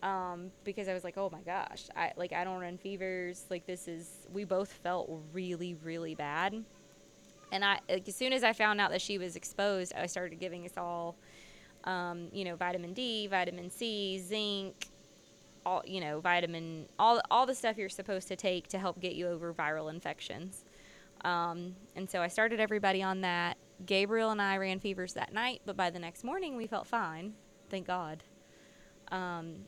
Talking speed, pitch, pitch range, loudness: 190 wpm, 185 Hz, 175-200 Hz, -35 LUFS